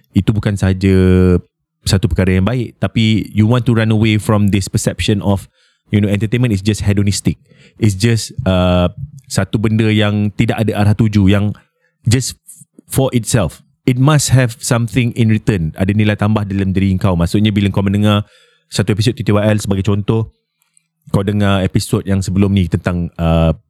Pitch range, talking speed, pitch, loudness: 100-115 Hz, 165 wpm, 105 Hz, -14 LUFS